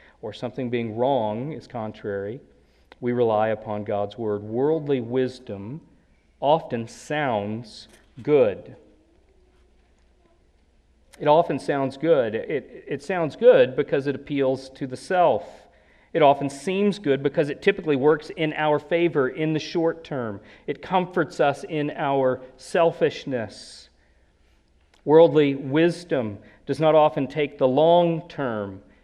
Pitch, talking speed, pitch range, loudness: 135 Hz, 125 wpm, 105-155 Hz, -23 LUFS